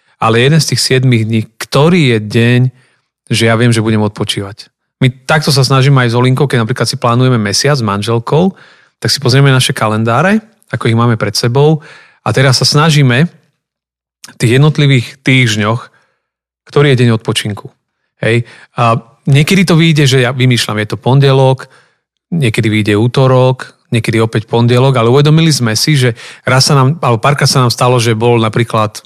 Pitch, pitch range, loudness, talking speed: 125 Hz, 115-140 Hz, -10 LUFS, 170 wpm